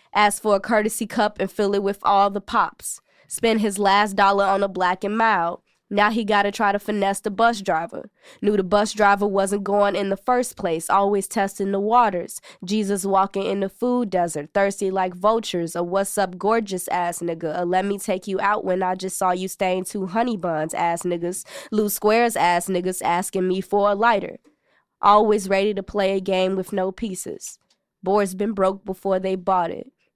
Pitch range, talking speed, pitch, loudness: 190-210 Hz, 200 wpm, 200 Hz, -21 LUFS